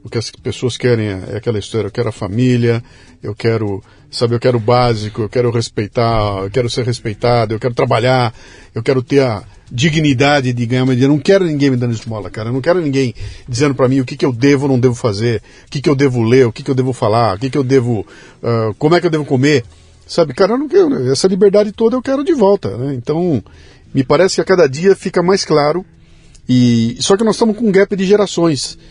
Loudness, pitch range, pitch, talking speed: -14 LUFS, 115-150 Hz, 130 Hz, 245 wpm